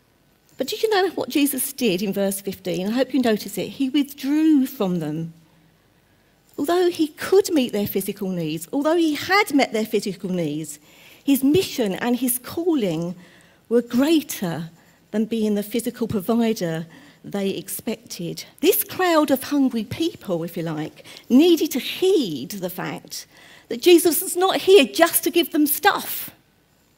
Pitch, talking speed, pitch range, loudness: 240 Hz, 155 wpm, 190-310 Hz, -21 LUFS